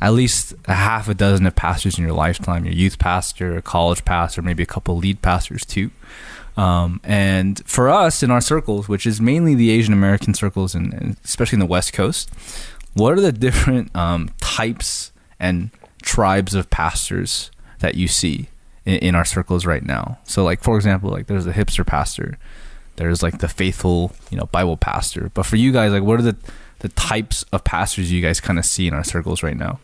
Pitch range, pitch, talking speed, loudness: 85-105 Hz, 95 Hz, 205 wpm, -18 LUFS